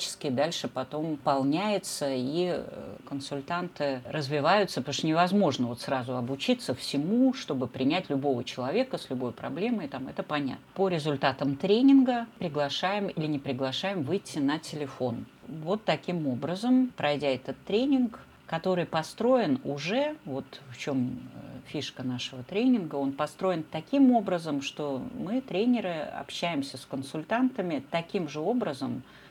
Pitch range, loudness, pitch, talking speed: 135-200 Hz, -29 LUFS, 155 Hz, 125 wpm